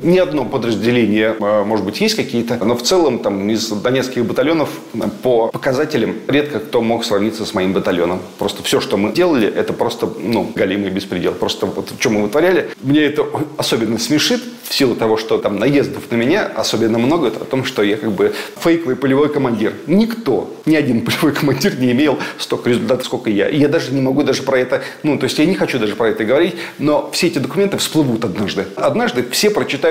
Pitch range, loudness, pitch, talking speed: 115-155 Hz, -16 LUFS, 130 Hz, 205 wpm